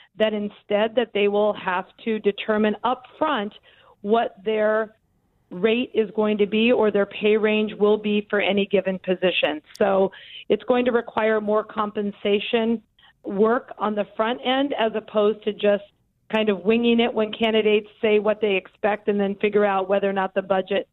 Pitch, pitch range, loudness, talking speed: 215 Hz, 205-220 Hz, -22 LUFS, 180 wpm